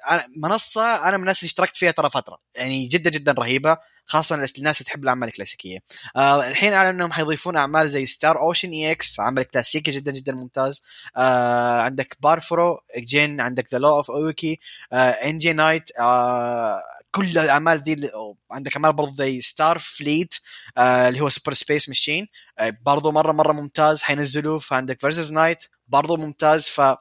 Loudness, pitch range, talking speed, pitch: -19 LUFS, 130-160 Hz, 160 wpm, 150 Hz